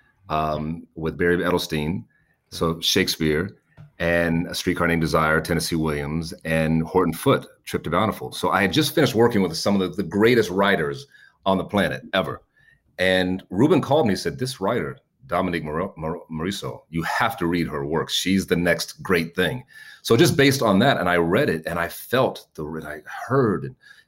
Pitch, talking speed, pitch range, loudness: 85 Hz, 185 wpm, 80-95 Hz, -22 LUFS